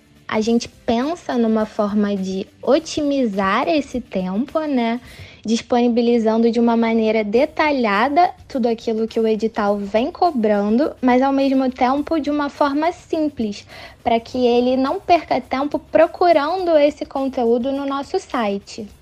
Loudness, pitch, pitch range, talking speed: -19 LUFS, 245 Hz, 225-295 Hz, 135 wpm